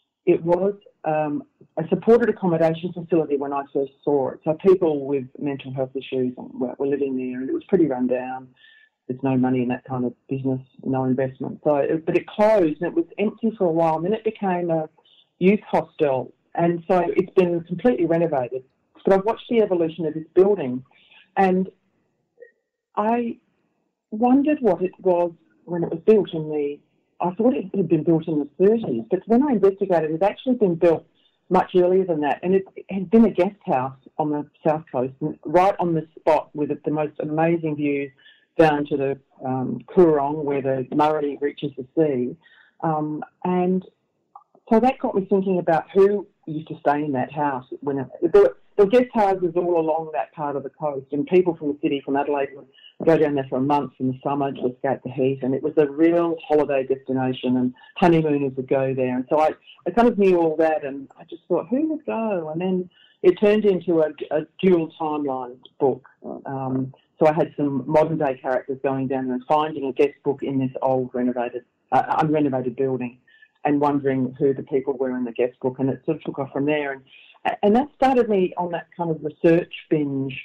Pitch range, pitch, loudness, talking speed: 135-185 Hz, 155 Hz, -22 LUFS, 205 wpm